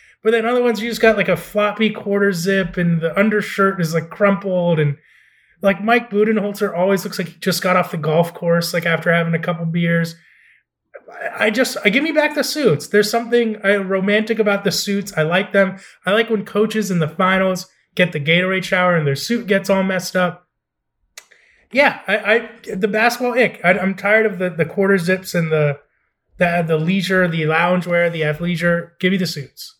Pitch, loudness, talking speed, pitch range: 190 Hz, -17 LUFS, 205 wpm, 175-210 Hz